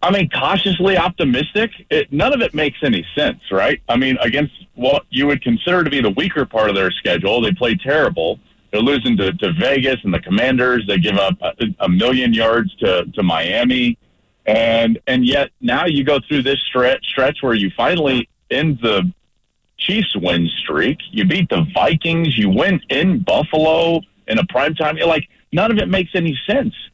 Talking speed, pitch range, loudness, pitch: 190 wpm, 130-195 Hz, -16 LUFS, 160 Hz